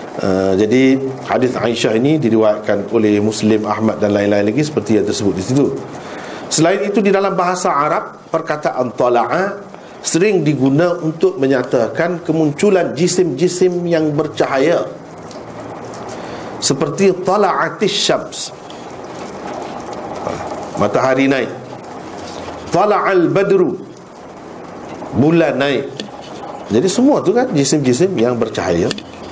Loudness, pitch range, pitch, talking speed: -15 LUFS, 115-180 Hz, 150 Hz, 100 wpm